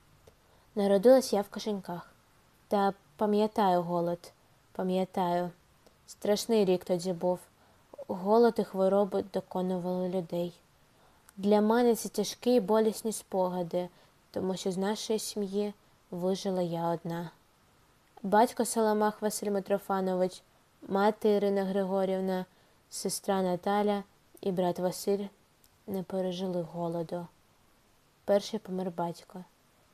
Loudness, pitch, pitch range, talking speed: -30 LUFS, 195 Hz, 180-210 Hz, 100 wpm